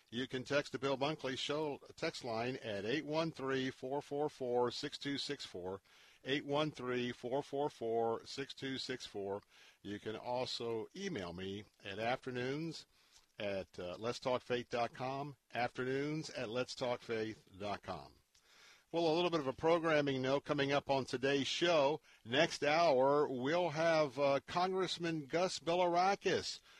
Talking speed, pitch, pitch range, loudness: 105 wpm, 135 Hz, 120-150 Hz, -38 LUFS